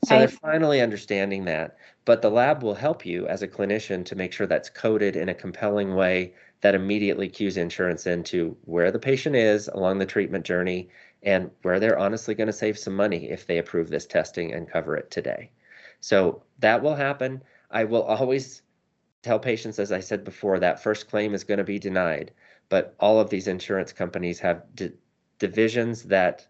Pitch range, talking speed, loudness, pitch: 95-110 Hz, 190 wpm, -25 LUFS, 105 Hz